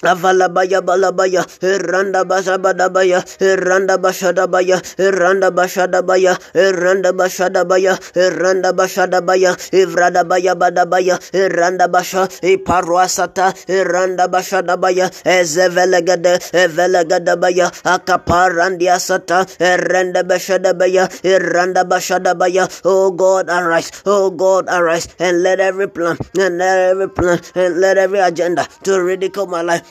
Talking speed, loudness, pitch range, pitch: 130 wpm, -14 LUFS, 180-185 Hz, 185 Hz